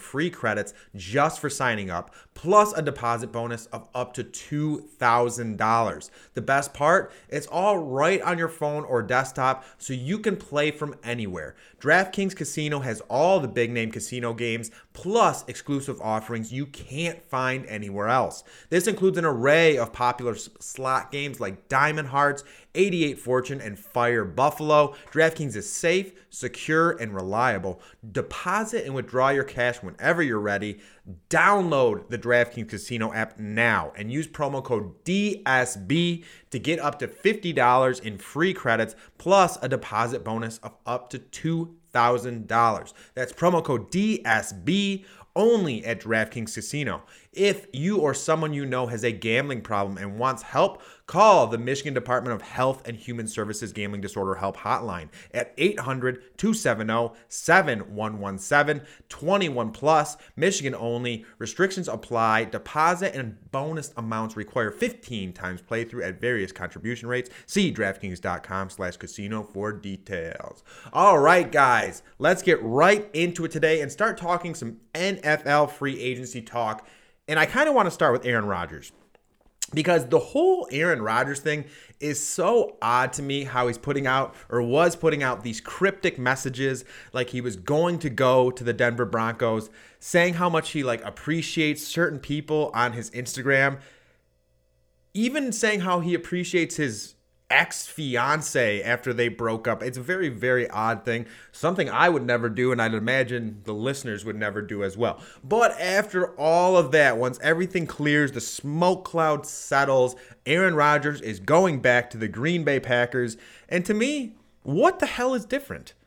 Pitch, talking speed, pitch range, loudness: 130 Hz, 150 wpm, 115-155 Hz, -24 LUFS